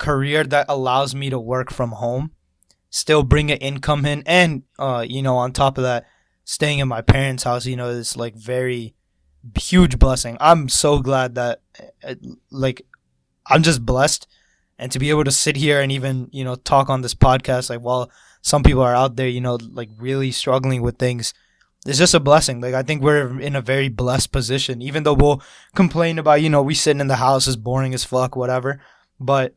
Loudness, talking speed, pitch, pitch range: -18 LUFS, 205 wpm, 130 Hz, 125-145 Hz